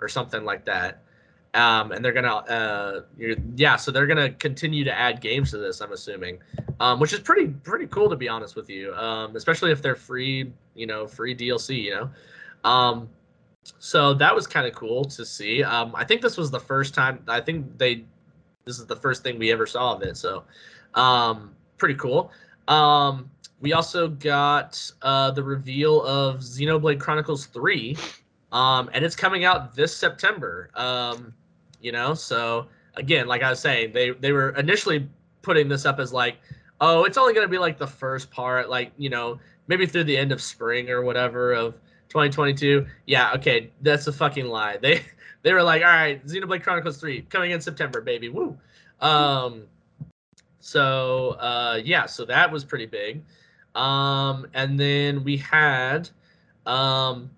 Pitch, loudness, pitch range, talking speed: 140 Hz, -22 LUFS, 125-155 Hz, 180 wpm